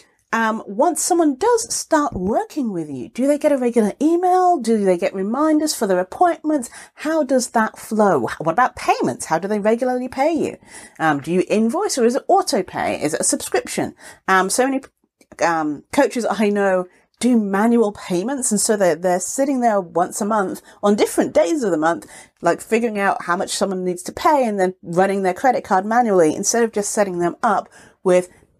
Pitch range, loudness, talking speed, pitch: 190-280 Hz, -19 LUFS, 200 wpm, 220 Hz